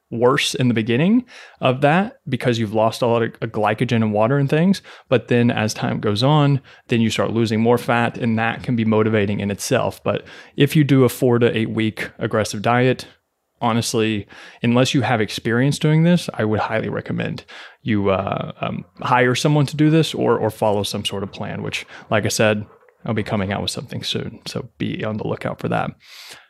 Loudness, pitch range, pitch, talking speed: -19 LUFS, 110-135 Hz, 120 Hz, 205 wpm